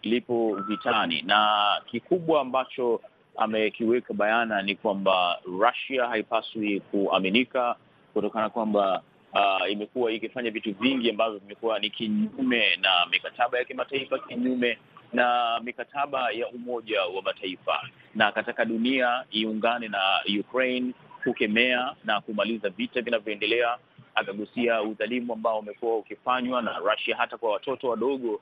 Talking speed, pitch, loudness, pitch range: 120 wpm, 115 Hz, -26 LUFS, 110-125 Hz